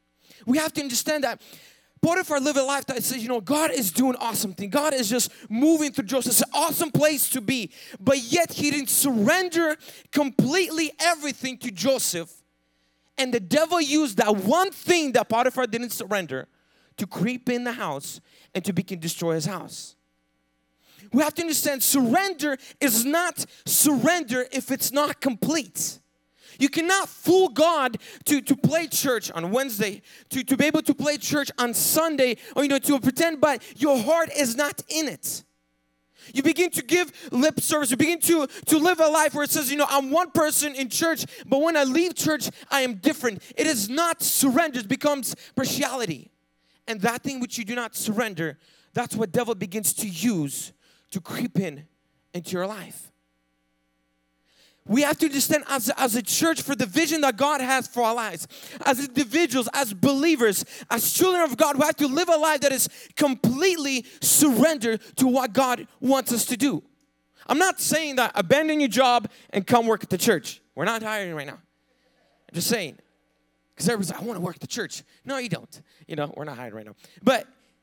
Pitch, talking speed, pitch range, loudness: 260 Hz, 190 wpm, 215-300 Hz, -23 LUFS